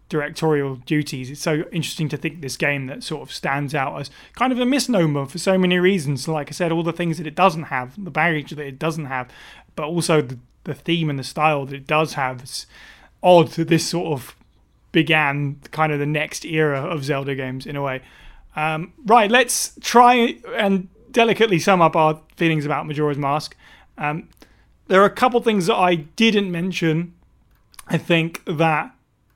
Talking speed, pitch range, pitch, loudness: 195 wpm, 145-175 Hz, 155 Hz, -20 LUFS